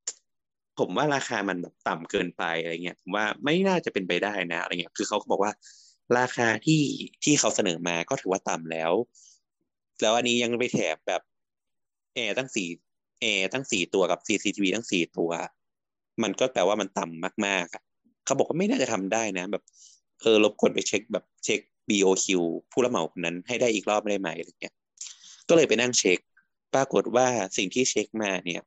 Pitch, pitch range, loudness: 100 Hz, 90-120 Hz, -26 LUFS